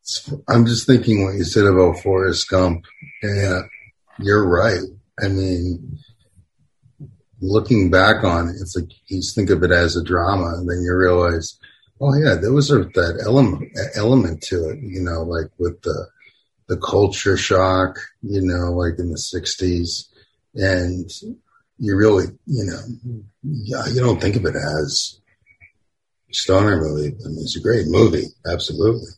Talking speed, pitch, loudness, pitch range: 155 wpm, 95 Hz, -19 LUFS, 90-115 Hz